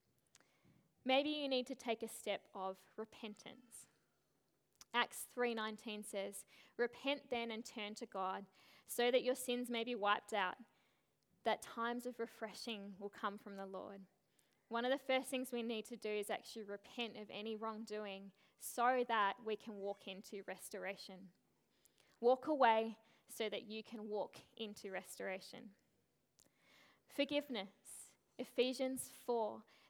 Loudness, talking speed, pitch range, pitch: -42 LUFS, 140 wpm, 205-245 Hz, 225 Hz